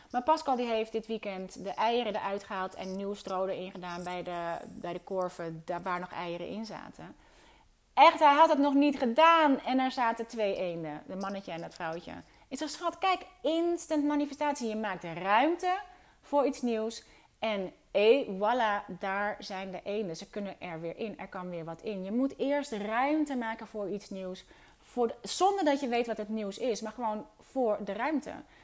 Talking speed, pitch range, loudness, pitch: 195 wpm, 190-270 Hz, -31 LUFS, 220 Hz